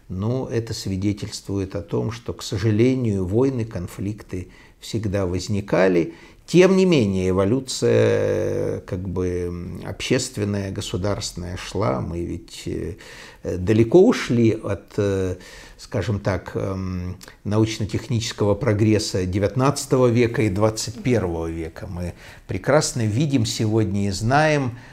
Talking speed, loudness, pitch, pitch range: 100 wpm, -22 LUFS, 110 Hz, 95-120 Hz